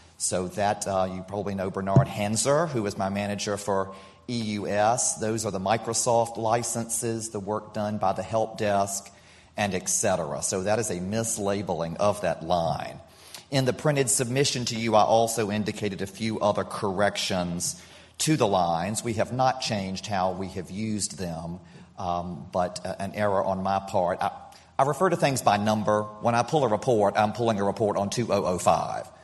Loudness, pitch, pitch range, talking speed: -26 LUFS, 105 Hz, 95-115 Hz, 180 wpm